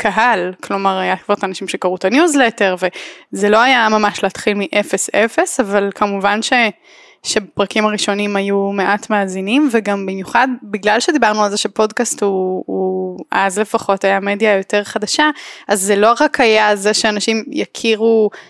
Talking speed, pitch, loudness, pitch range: 150 wpm, 210 Hz, -15 LUFS, 195-225 Hz